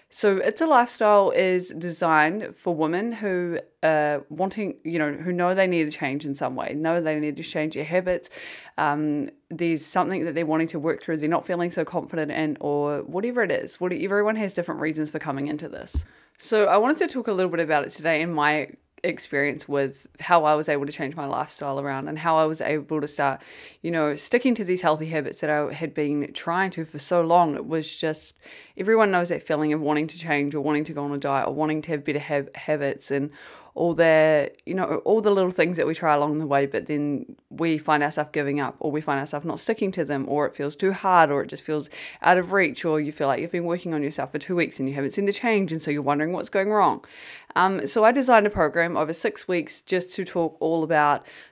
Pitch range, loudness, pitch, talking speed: 150-180 Hz, -24 LUFS, 160 Hz, 245 wpm